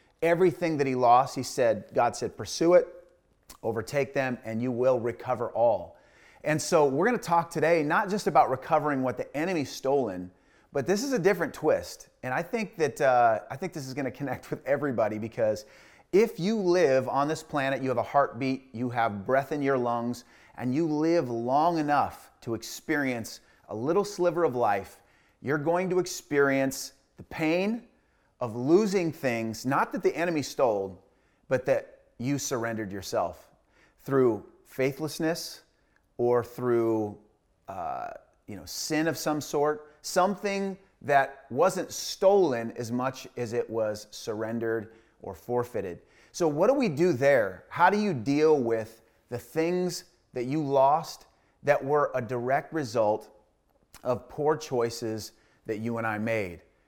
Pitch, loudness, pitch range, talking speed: 135 Hz, -28 LUFS, 115-165 Hz, 160 wpm